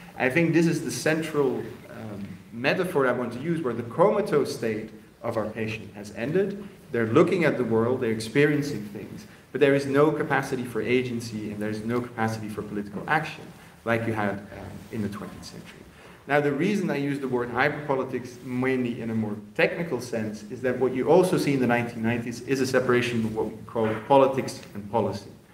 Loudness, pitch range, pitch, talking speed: -26 LUFS, 110-140 Hz, 120 Hz, 195 wpm